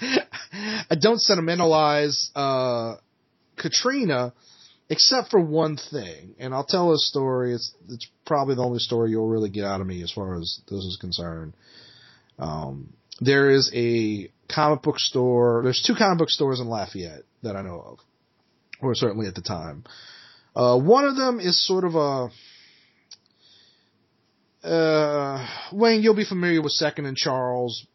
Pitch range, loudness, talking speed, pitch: 110-160 Hz, -22 LUFS, 155 wpm, 130 Hz